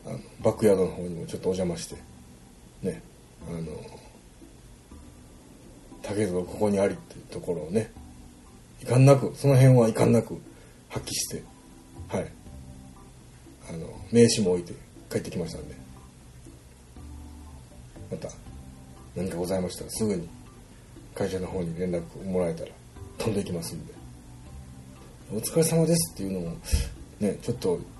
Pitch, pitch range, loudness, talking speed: 75 Hz, 65-95 Hz, -27 LUFS, 275 characters per minute